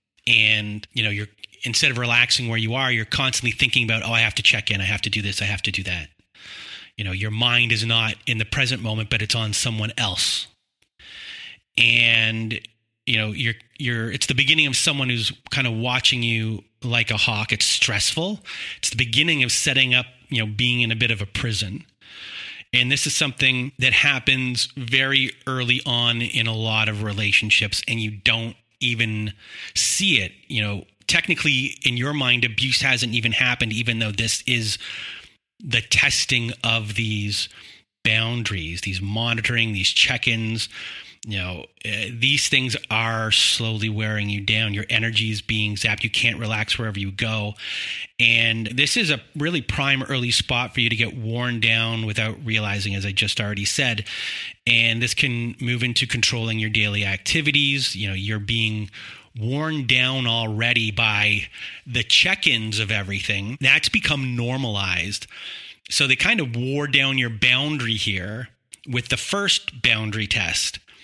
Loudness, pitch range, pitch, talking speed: -20 LUFS, 110-125 Hz, 115 Hz, 170 wpm